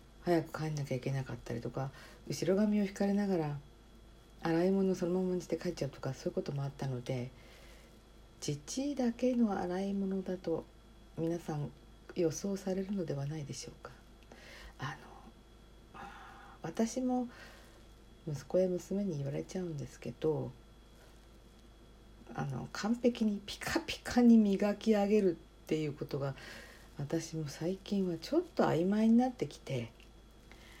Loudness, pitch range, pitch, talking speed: -35 LUFS, 125-195 Hz, 160 Hz, 275 characters per minute